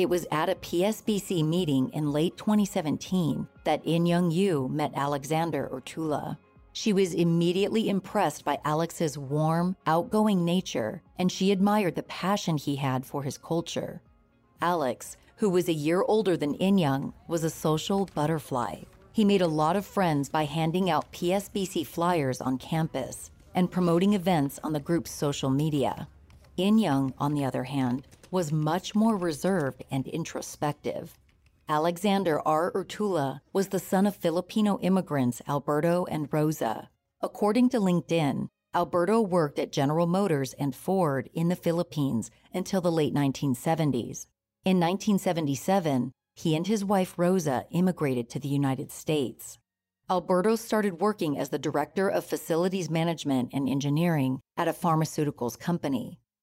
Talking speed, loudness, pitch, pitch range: 140 wpm, -28 LUFS, 165 Hz, 145-185 Hz